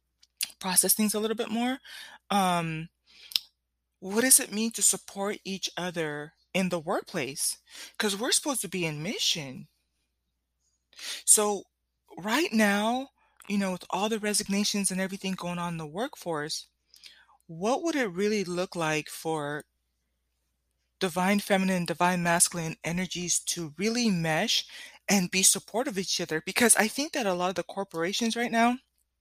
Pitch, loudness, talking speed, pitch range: 185 Hz, -27 LUFS, 150 wpm, 160-210 Hz